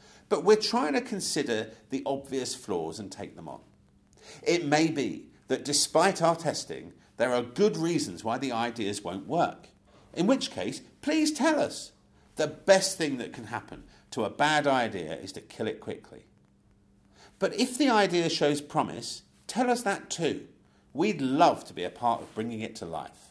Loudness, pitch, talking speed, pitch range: -28 LUFS, 155 Hz, 180 wpm, 125-210 Hz